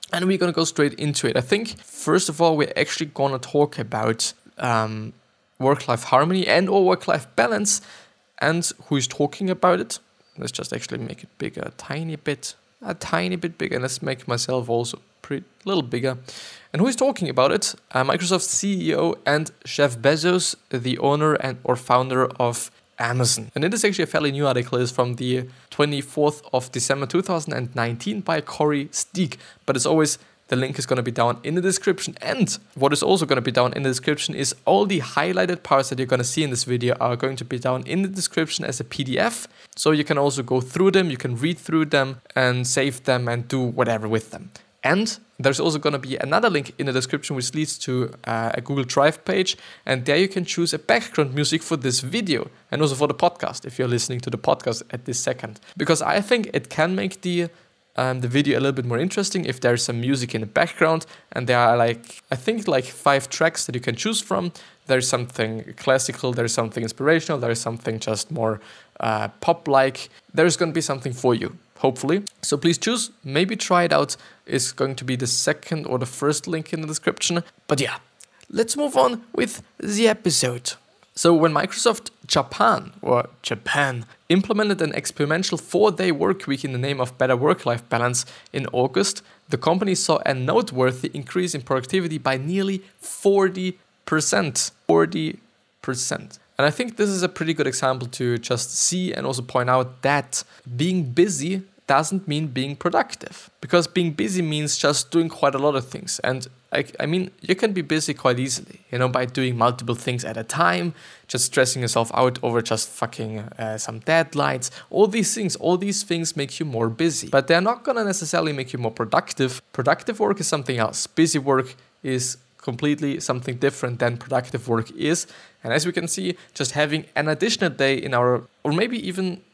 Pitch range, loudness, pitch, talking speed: 125-175 Hz, -22 LUFS, 145 Hz, 200 wpm